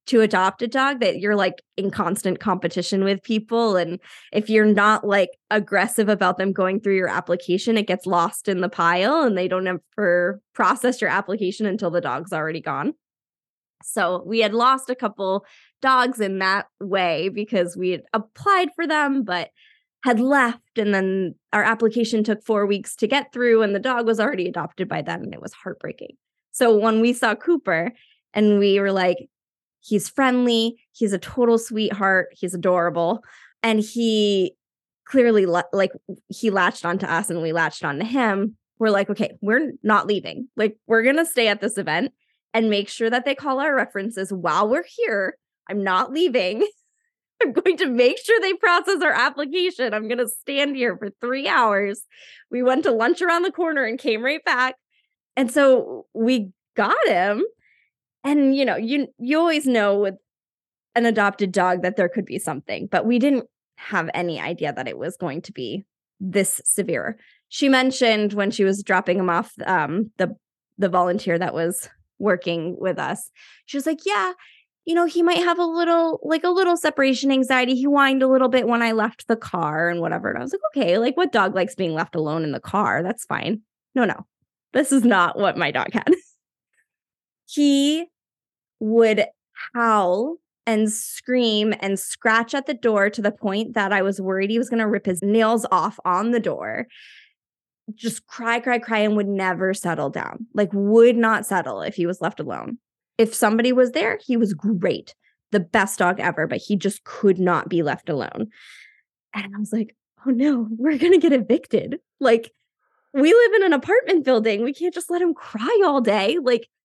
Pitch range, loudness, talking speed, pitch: 195-265 Hz, -21 LUFS, 190 wpm, 220 Hz